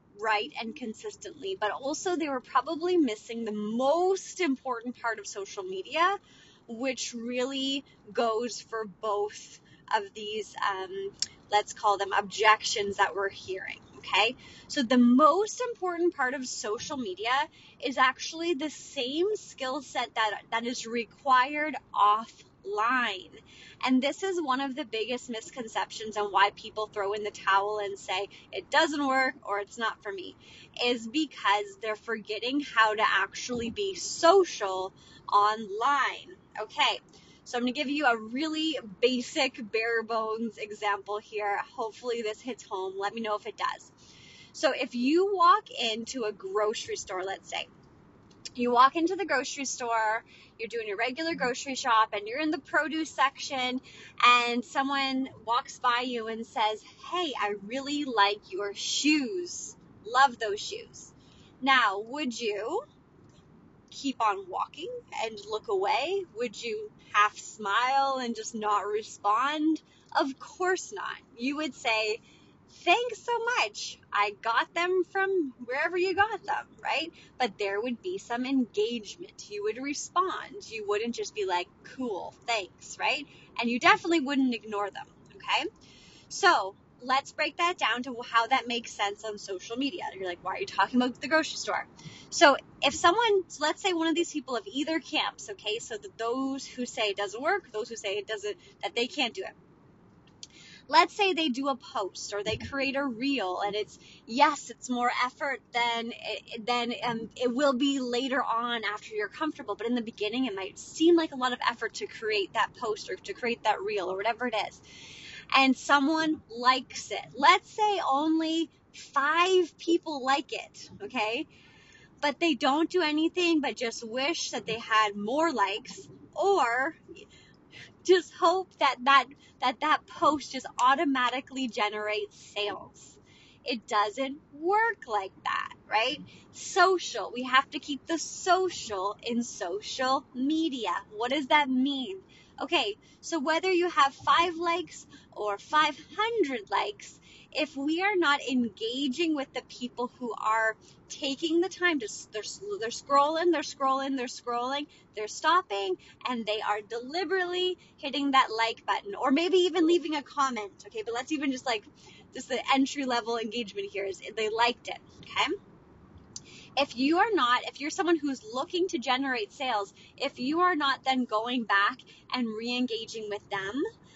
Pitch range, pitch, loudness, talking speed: 220-315 Hz, 255 Hz, -29 LUFS, 160 wpm